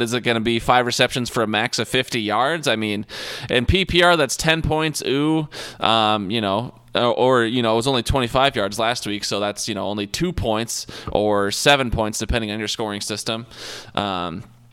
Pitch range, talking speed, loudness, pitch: 105-125 Hz, 210 wpm, -20 LUFS, 115 Hz